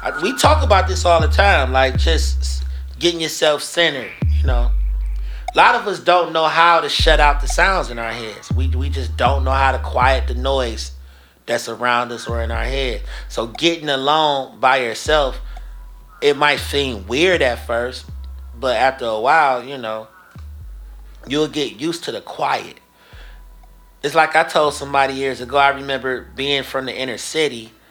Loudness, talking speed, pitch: -17 LUFS, 180 wpm, 115 Hz